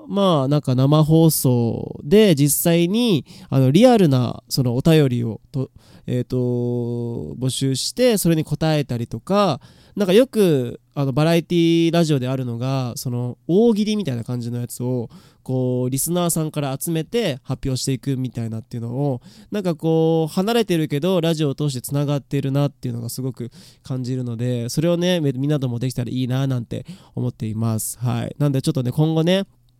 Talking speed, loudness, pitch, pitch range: 345 characters per minute, -20 LUFS, 135 Hz, 125-165 Hz